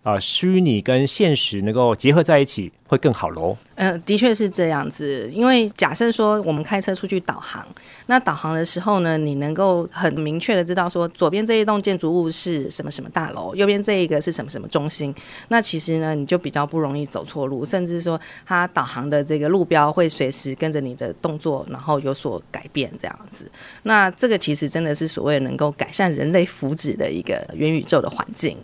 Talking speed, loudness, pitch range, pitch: 315 characters per minute, -20 LUFS, 145-190 Hz, 165 Hz